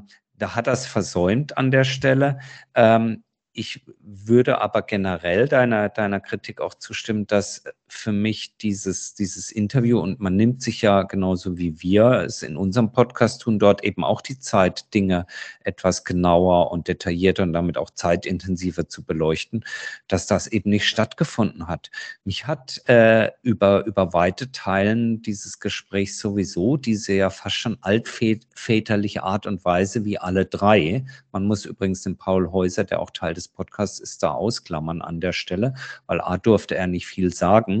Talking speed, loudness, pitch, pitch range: 165 wpm, -22 LUFS, 100 Hz, 95-110 Hz